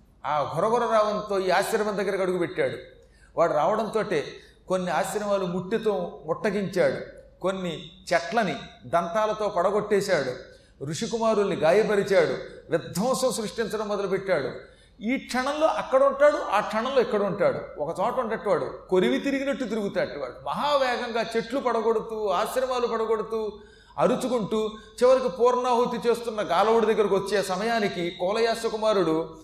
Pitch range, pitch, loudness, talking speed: 195-245 Hz, 220 Hz, -25 LUFS, 110 wpm